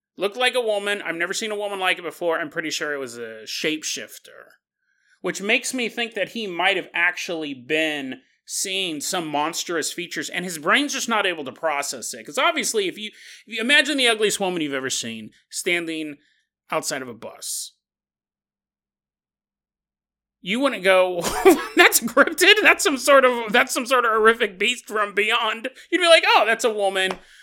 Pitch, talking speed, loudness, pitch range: 205 Hz, 185 wpm, -20 LUFS, 175-260 Hz